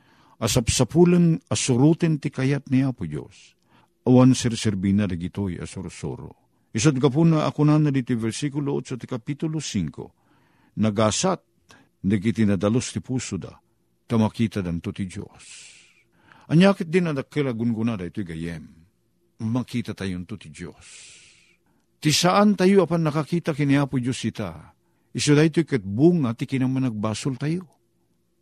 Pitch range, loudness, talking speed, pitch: 105-150 Hz, -23 LUFS, 130 wpm, 125 Hz